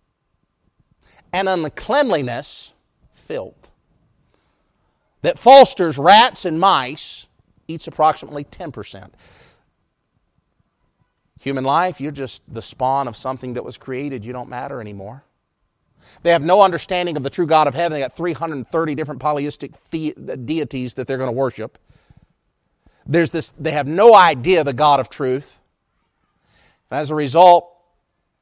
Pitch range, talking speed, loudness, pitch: 130-170 Hz, 130 wpm, -16 LUFS, 150 Hz